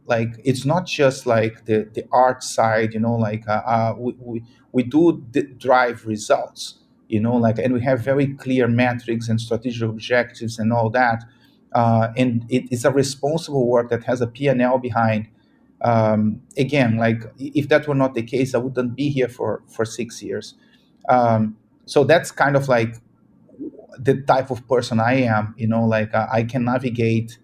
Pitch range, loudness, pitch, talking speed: 115-130 Hz, -20 LUFS, 120 Hz, 185 wpm